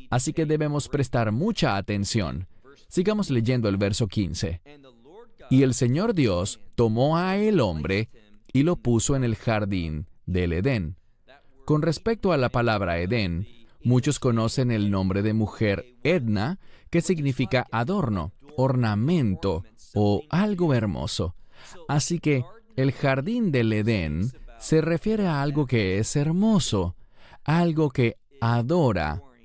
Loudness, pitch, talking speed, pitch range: -24 LUFS, 120 Hz, 130 wpm, 105-150 Hz